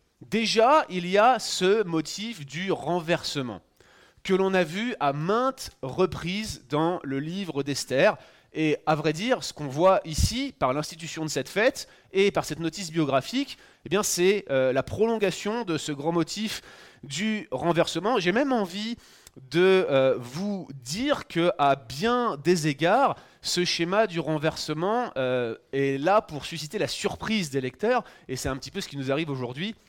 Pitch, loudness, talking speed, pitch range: 170 Hz, -26 LUFS, 170 wpm, 145-205 Hz